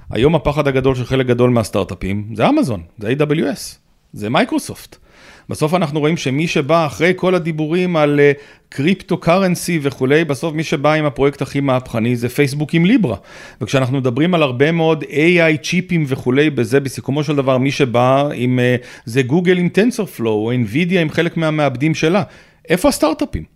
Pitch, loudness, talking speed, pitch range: 150 Hz, -16 LUFS, 165 wpm, 130-165 Hz